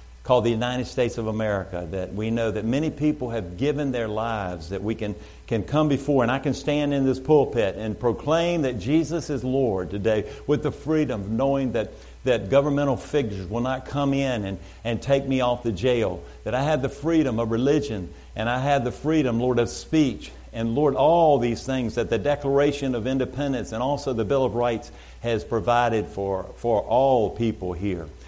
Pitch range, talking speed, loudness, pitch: 110-140 Hz, 200 wpm, -24 LUFS, 120 Hz